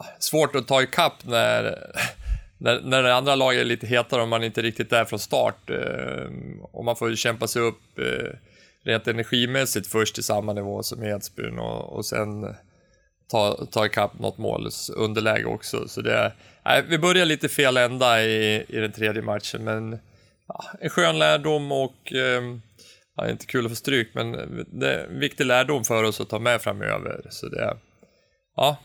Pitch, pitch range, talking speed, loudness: 115 Hz, 110-130 Hz, 185 wpm, -23 LUFS